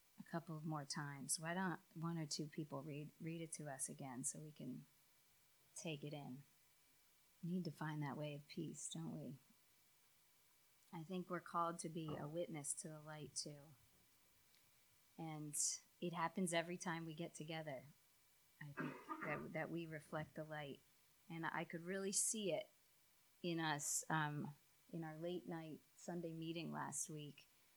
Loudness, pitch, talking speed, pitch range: -47 LUFS, 160 Hz, 170 wpm, 150-170 Hz